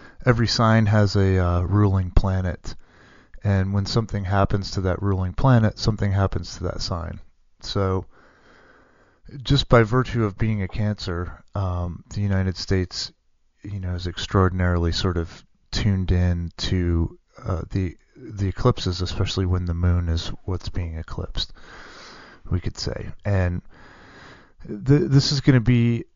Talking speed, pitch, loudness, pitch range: 145 wpm, 95 Hz, -23 LUFS, 90-105 Hz